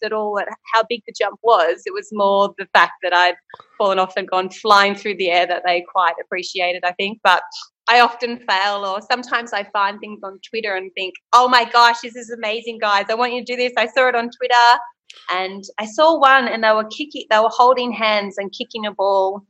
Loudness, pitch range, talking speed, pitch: -17 LUFS, 195-240 Hz, 235 wpm, 215 Hz